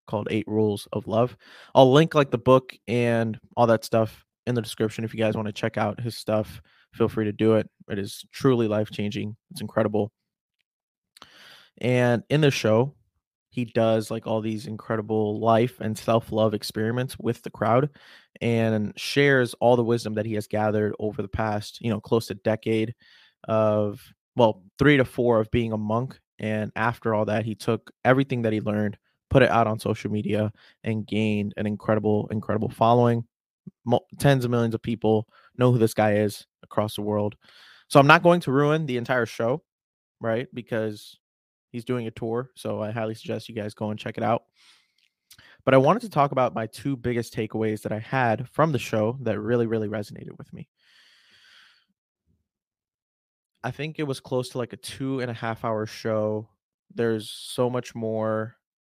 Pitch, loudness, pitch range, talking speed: 110 Hz, -24 LUFS, 105-120 Hz, 185 wpm